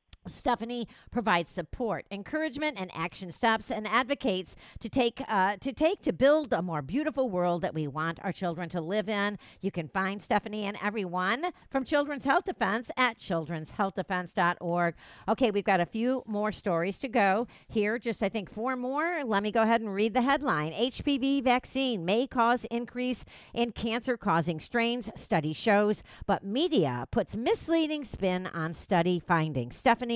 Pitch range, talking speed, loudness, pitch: 185-250 Hz, 165 wpm, -29 LUFS, 215 Hz